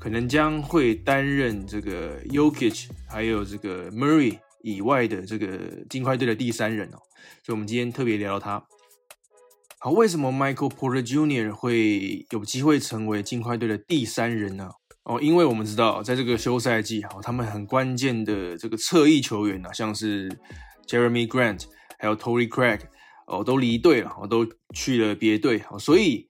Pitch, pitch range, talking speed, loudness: 115 Hz, 105-130 Hz, 330 characters per minute, -24 LUFS